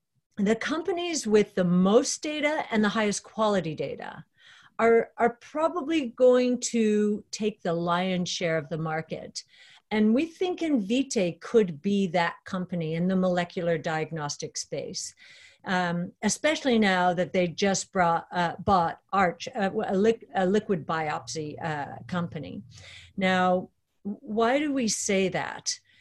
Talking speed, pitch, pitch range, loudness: 135 wpm, 200 Hz, 175-245 Hz, -26 LUFS